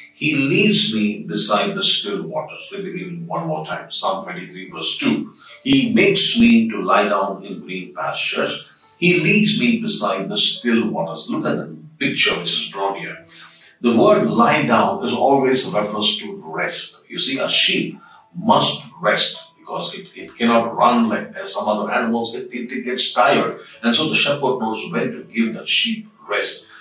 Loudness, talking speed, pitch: -17 LUFS, 180 wpm, 175 Hz